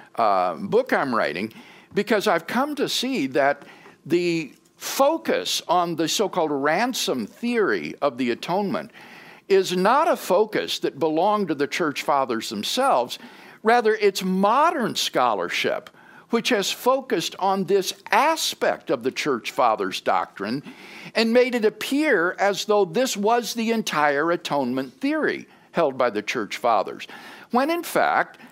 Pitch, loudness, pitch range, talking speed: 210 Hz, -22 LUFS, 175-255 Hz, 140 wpm